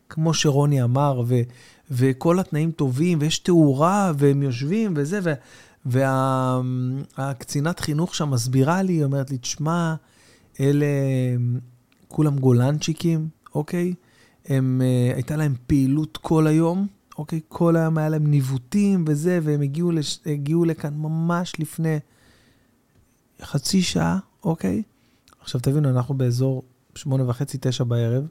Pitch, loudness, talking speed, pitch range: 145 Hz, -22 LUFS, 125 wpm, 130-165 Hz